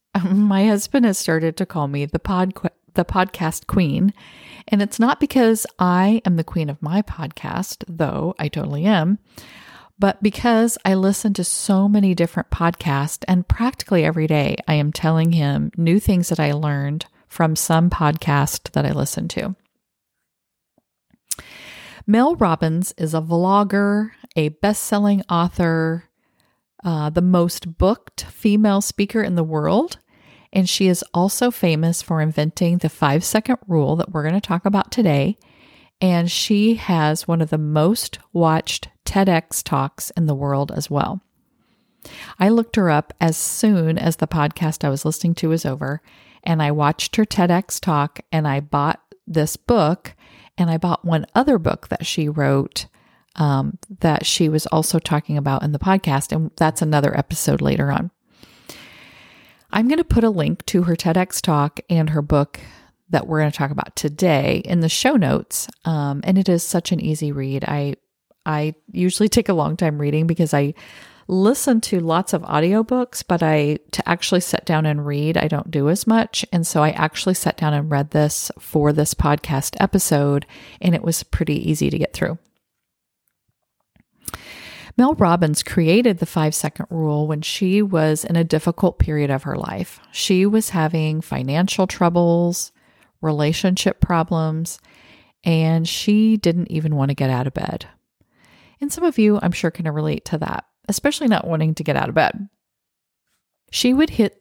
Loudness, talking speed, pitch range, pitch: -19 LUFS, 170 wpm, 155-195 Hz, 170 Hz